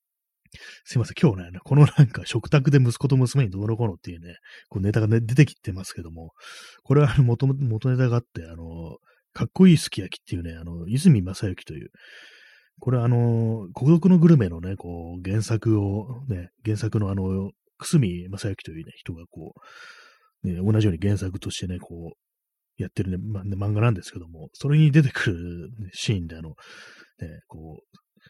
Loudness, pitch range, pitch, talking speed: -22 LUFS, 90-125 Hz, 110 Hz, 350 characters per minute